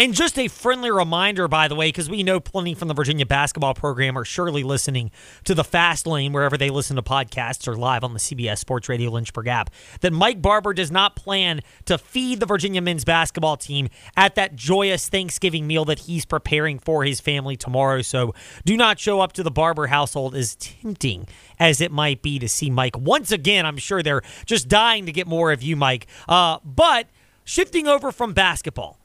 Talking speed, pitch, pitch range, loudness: 205 wpm, 155 Hz, 135-190 Hz, -20 LUFS